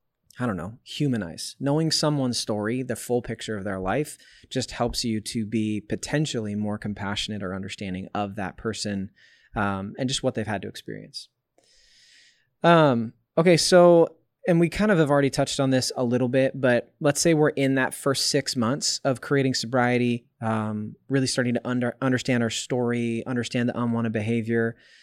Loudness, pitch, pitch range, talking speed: -24 LUFS, 120 Hz, 110-140 Hz, 175 wpm